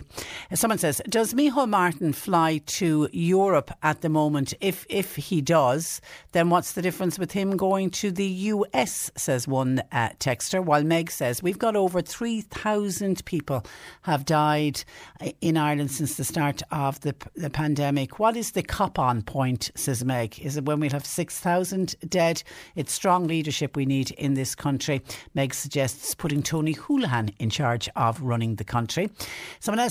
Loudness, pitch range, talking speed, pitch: -25 LUFS, 135-185 Hz, 165 wpm, 155 Hz